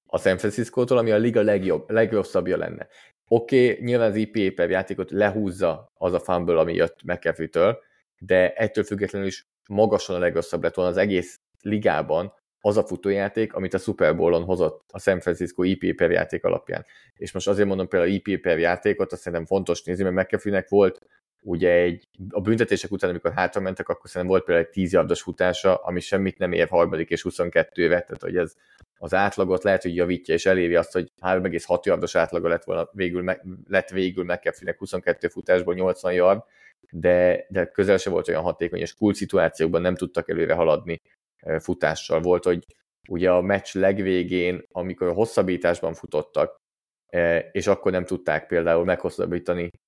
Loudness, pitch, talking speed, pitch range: -23 LUFS, 95 Hz, 175 wpm, 90-100 Hz